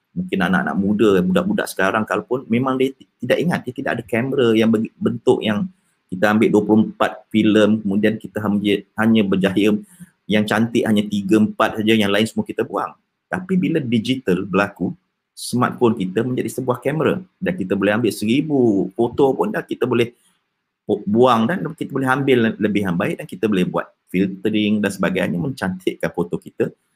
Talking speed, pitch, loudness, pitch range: 165 wpm, 110 Hz, -19 LUFS, 105-135 Hz